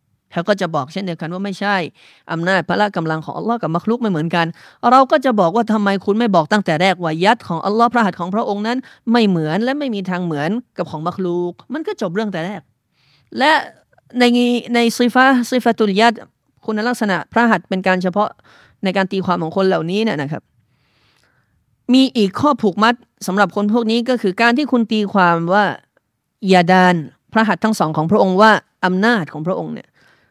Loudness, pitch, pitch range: -16 LUFS, 205 Hz, 180-235 Hz